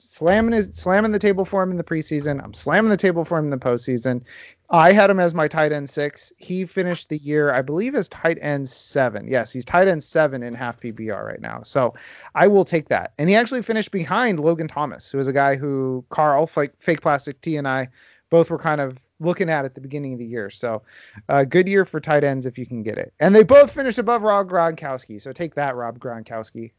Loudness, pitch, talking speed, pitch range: -20 LUFS, 150 Hz, 240 wpm, 130-185 Hz